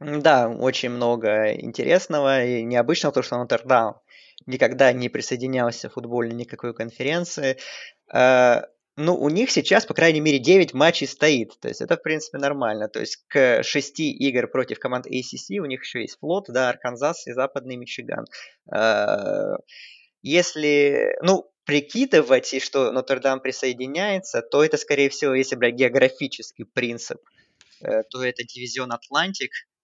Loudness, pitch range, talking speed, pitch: -22 LUFS, 125-150 Hz, 140 wpm, 135 Hz